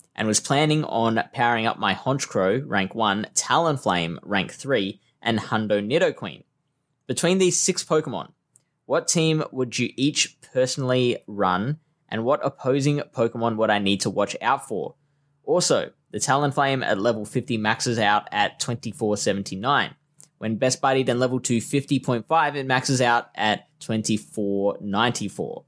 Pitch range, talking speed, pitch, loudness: 110-145 Hz, 140 wpm, 125 Hz, -23 LUFS